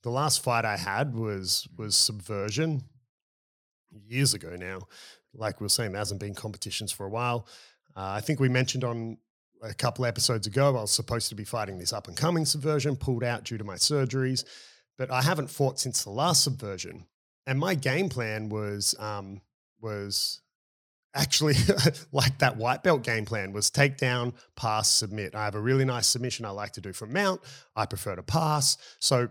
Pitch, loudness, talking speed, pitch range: 120 Hz, -27 LUFS, 190 wpm, 105-135 Hz